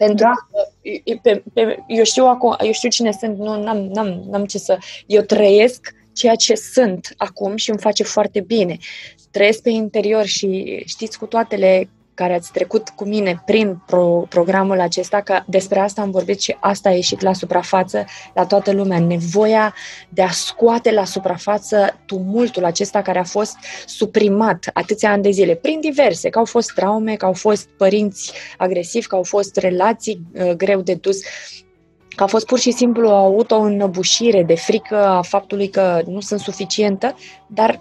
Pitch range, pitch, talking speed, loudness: 190-220 Hz, 205 Hz, 165 wpm, -17 LUFS